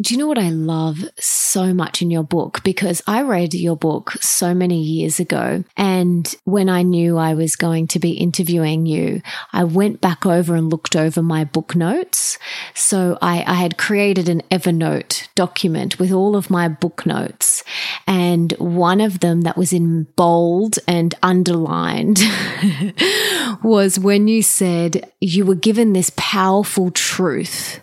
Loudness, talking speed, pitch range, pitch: -17 LUFS, 160 wpm, 170-195 Hz, 180 Hz